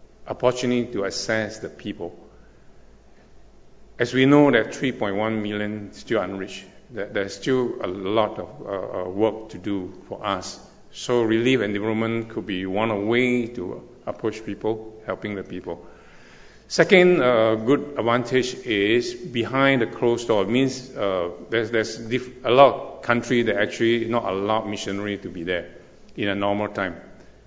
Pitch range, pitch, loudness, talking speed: 105-125 Hz, 115 Hz, -23 LUFS, 155 wpm